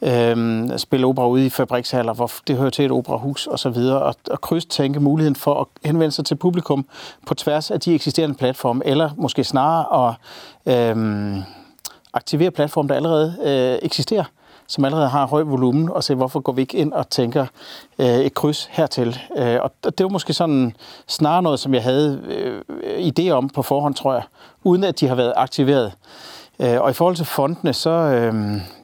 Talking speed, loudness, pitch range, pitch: 185 wpm, -19 LUFS, 125-160 Hz, 140 Hz